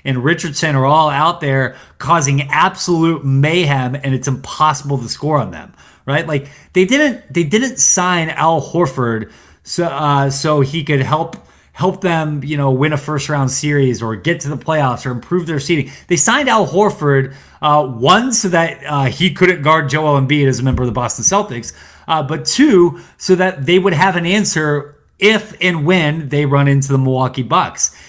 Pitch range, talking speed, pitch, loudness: 135-175 Hz, 190 wpm, 150 Hz, -14 LUFS